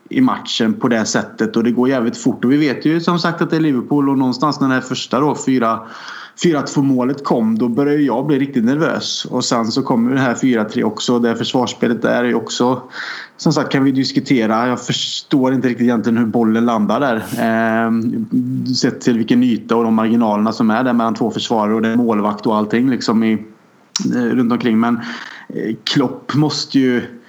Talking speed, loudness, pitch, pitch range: 210 wpm, -16 LUFS, 125 Hz, 115-145 Hz